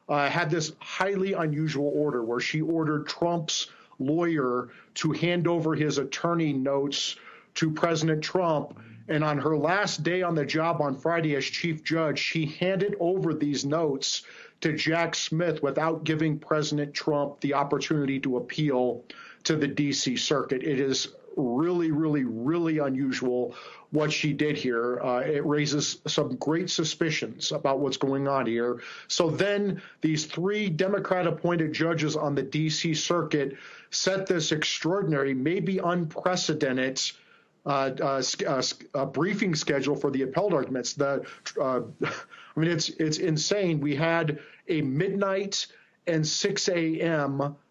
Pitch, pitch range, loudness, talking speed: 155 Hz, 140-170 Hz, -27 LUFS, 145 wpm